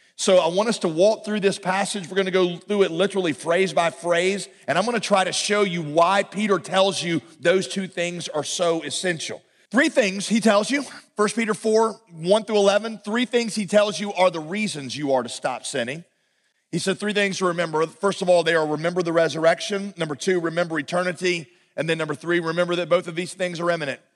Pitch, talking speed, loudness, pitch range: 185 Hz, 225 wpm, -22 LUFS, 170-205 Hz